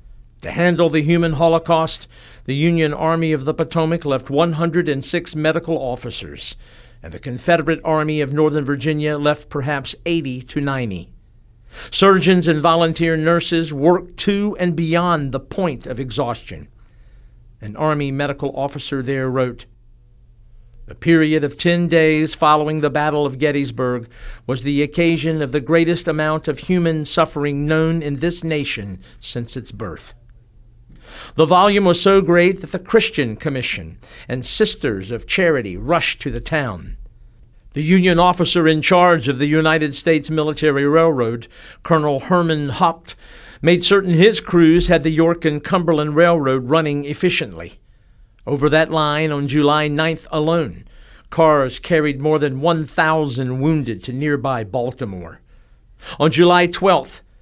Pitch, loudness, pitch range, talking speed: 150 Hz, -17 LUFS, 130-165 Hz, 140 wpm